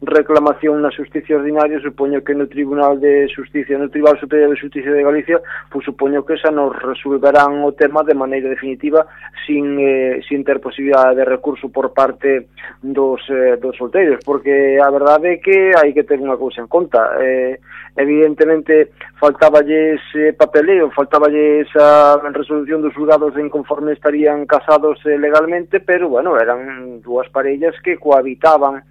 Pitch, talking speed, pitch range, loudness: 145 Hz, 160 wpm, 135-150 Hz, -14 LUFS